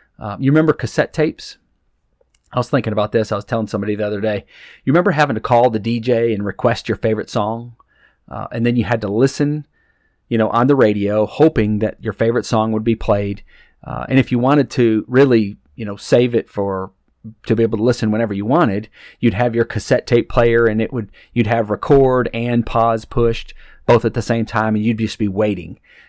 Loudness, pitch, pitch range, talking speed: -17 LUFS, 115 Hz, 110-120 Hz, 215 wpm